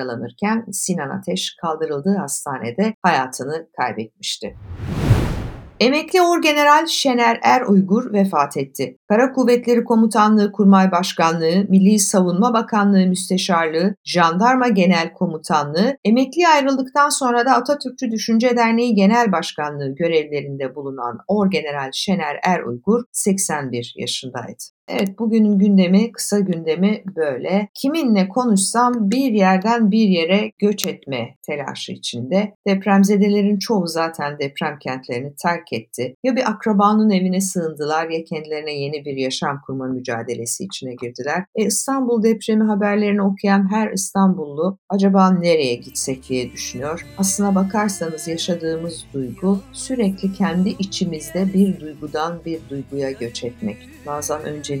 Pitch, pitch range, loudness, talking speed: 190 Hz, 155-215 Hz, -18 LUFS, 115 wpm